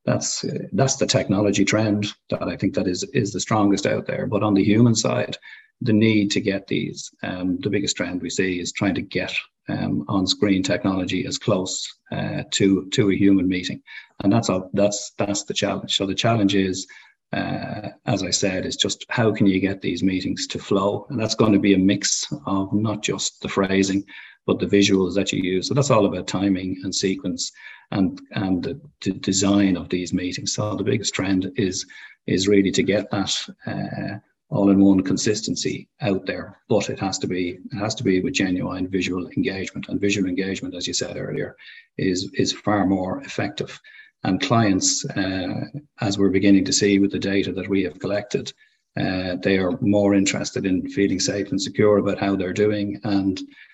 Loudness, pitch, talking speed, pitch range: -22 LUFS, 100 Hz, 195 wpm, 95-105 Hz